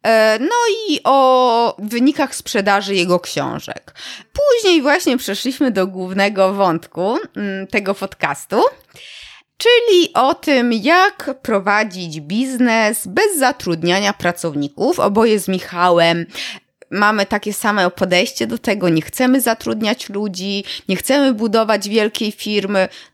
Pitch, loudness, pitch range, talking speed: 210 Hz, -16 LUFS, 195-260 Hz, 110 wpm